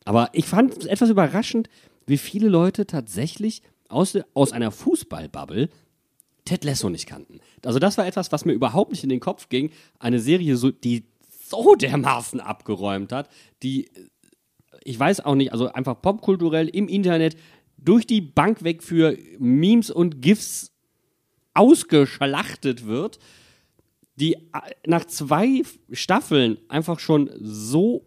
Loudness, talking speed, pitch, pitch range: -21 LUFS, 140 wpm, 160 Hz, 130-195 Hz